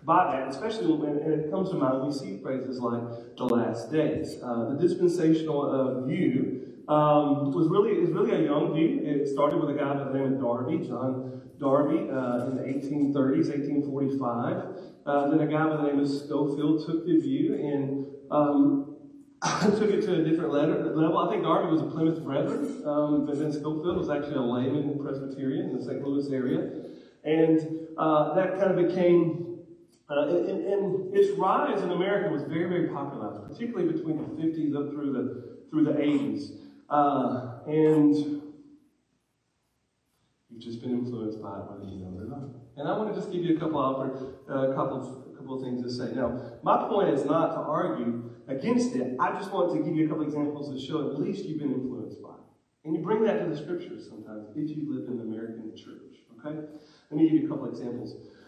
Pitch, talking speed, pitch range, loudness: 150 Hz, 205 wpm, 135-165 Hz, -27 LUFS